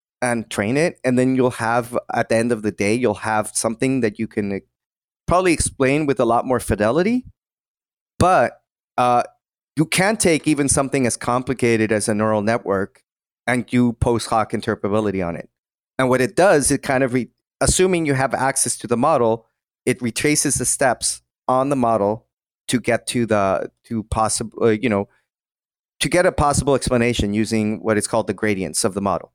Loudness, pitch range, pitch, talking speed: -19 LUFS, 110-130 Hz, 120 Hz, 190 wpm